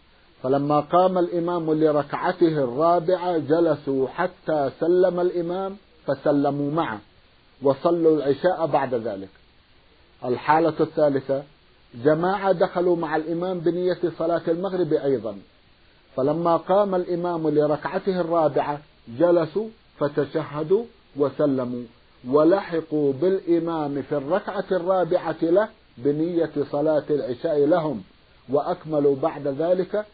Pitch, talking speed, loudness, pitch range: 160 Hz, 90 wpm, -23 LUFS, 145-175 Hz